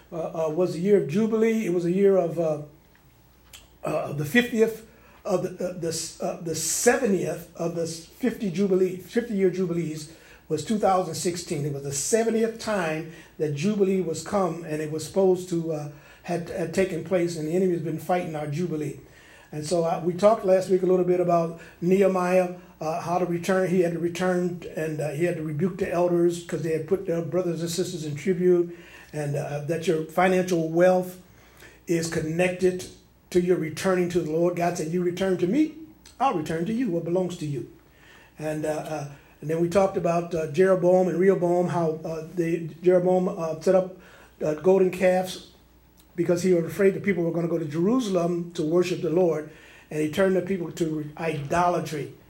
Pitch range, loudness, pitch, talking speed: 160-185 Hz, -25 LUFS, 175 Hz, 200 wpm